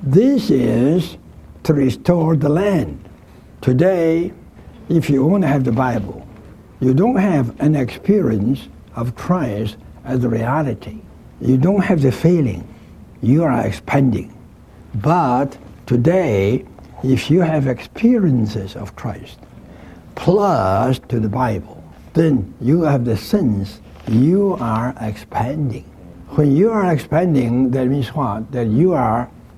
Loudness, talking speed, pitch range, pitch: -17 LUFS, 125 wpm, 110-160 Hz, 130 Hz